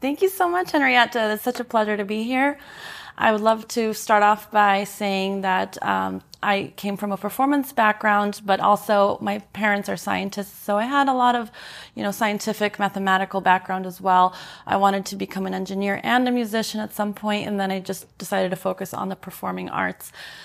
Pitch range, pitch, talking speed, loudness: 195-220 Hz, 205 Hz, 205 wpm, -22 LUFS